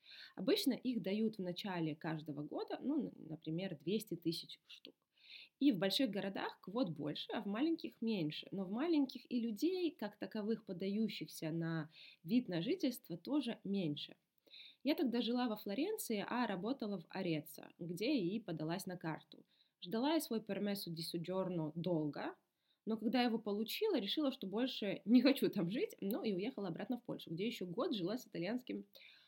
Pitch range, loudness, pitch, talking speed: 170-250 Hz, -40 LUFS, 210 Hz, 160 wpm